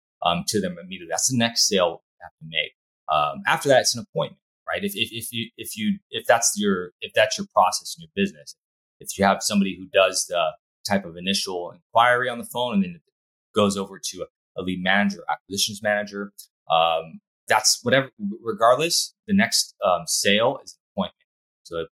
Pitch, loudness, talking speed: 115 Hz, -22 LUFS, 200 wpm